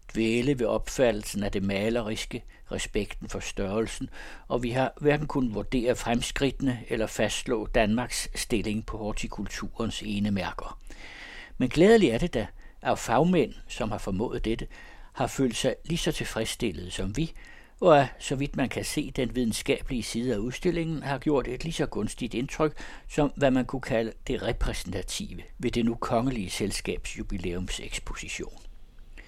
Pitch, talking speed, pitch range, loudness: 120 Hz, 150 wpm, 110-135 Hz, -28 LUFS